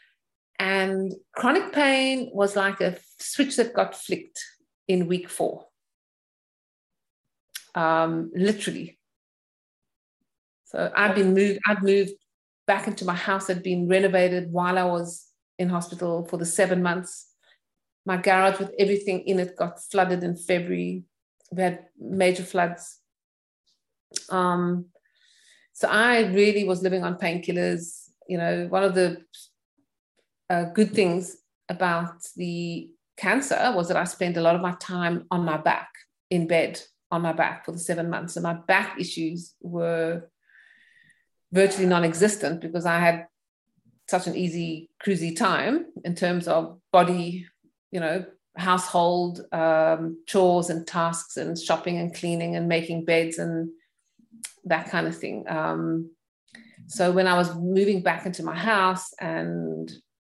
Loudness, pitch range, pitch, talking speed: -25 LUFS, 170-195 Hz, 180 Hz, 140 wpm